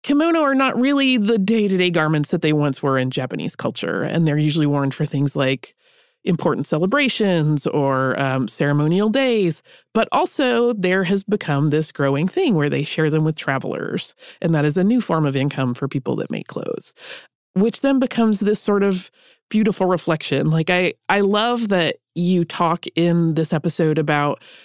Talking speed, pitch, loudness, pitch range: 180 wpm, 170 Hz, -19 LUFS, 150-215 Hz